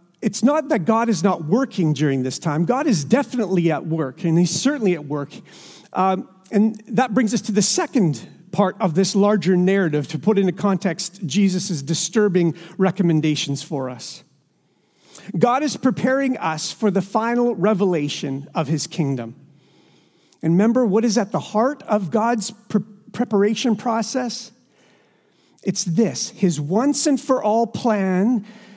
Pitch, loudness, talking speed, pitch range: 195 Hz, -20 LUFS, 150 wpm, 170-230 Hz